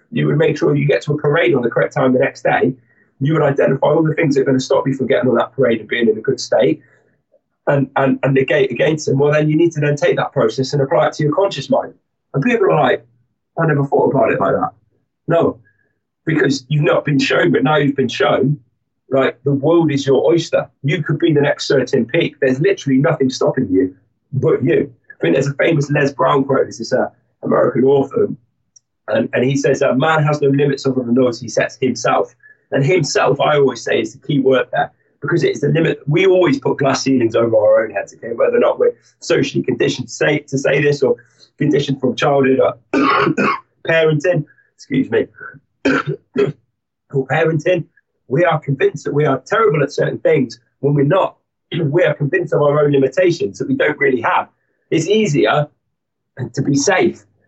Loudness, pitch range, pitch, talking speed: -16 LUFS, 135-155 Hz, 140 Hz, 220 wpm